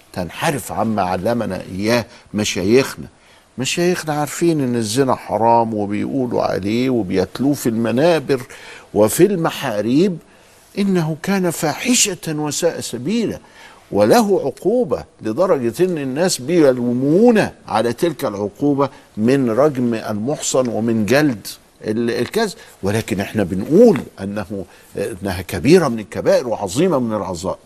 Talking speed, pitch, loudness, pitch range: 105 wpm, 125 Hz, -18 LUFS, 110-160 Hz